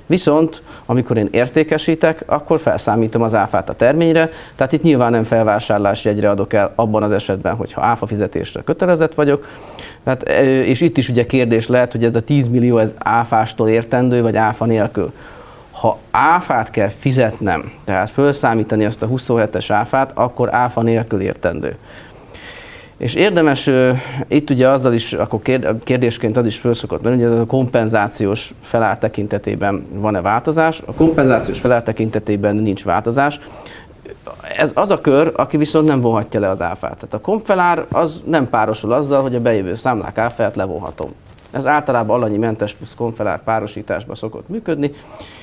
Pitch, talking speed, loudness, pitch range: 120 Hz, 155 wpm, -16 LUFS, 110-140 Hz